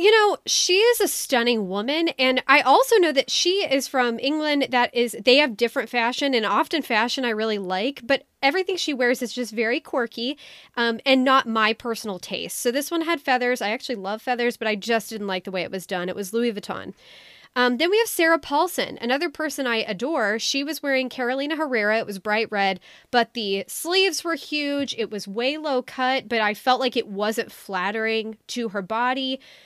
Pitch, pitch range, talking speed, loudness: 250 Hz, 220-280 Hz, 210 wpm, -22 LUFS